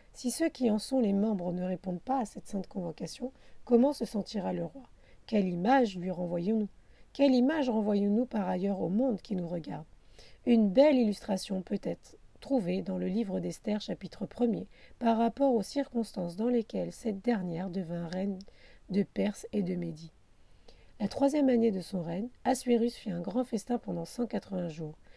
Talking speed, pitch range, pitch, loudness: 175 wpm, 180-240 Hz, 205 Hz, -31 LUFS